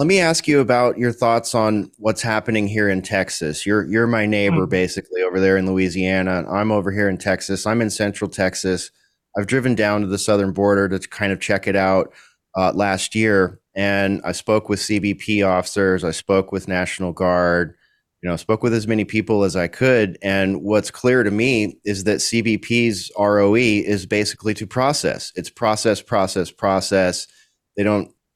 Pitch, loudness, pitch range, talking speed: 100 Hz, -19 LUFS, 95-110 Hz, 185 wpm